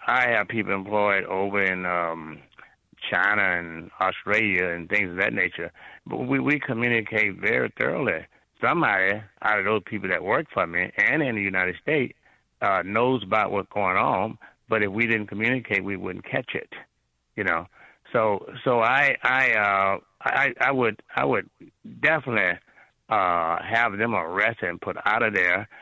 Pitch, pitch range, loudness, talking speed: 100 Hz, 95-110 Hz, -24 LUFS, 165 wpm